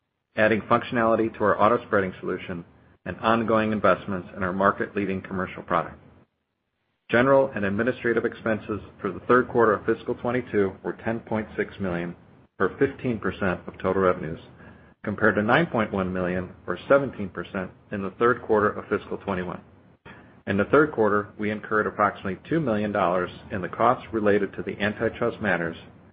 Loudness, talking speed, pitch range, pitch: -25 LUFS, 170 wpm, 95-115 Hz, 105 Hz